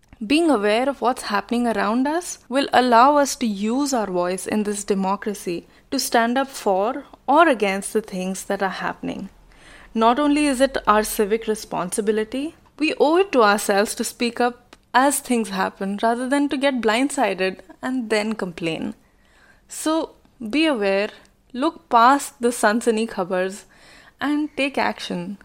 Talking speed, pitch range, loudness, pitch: 155 wpm, 205-275 Hz, -21 LUFS, 230 Hz